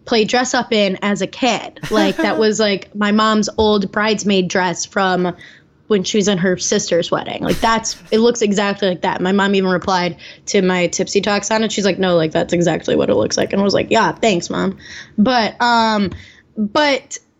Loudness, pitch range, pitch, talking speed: -16 LUFS, 185-220 Hz, 200 Hz, 210 wpm